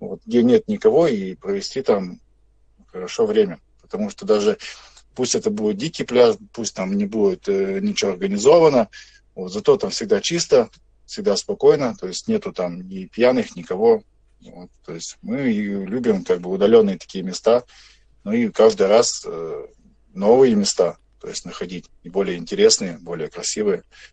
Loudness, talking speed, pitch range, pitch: -19 LUFS, 155 wpm, 195-235 Hz, 215 Hz